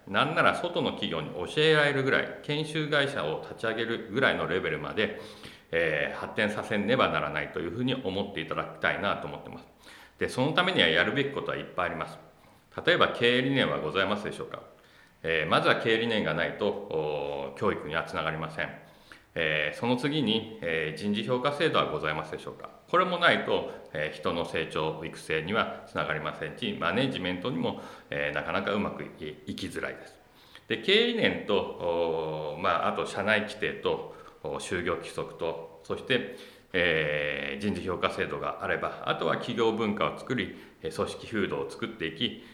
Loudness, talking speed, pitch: -29 LUFS, 375 characters per minute, 145 Hz